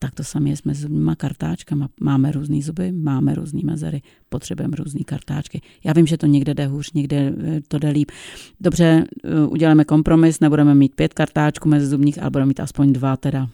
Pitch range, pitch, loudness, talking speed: 140-155 Hz, 150 Hz, -19 LUFS, 185 wpm